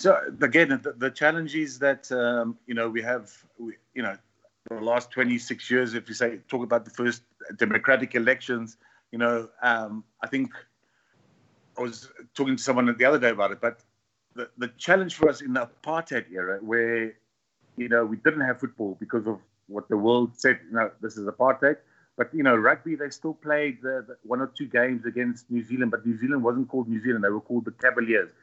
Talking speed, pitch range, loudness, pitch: 215 wpm, 115-135 Hz, -25 LUFS, 120 Hz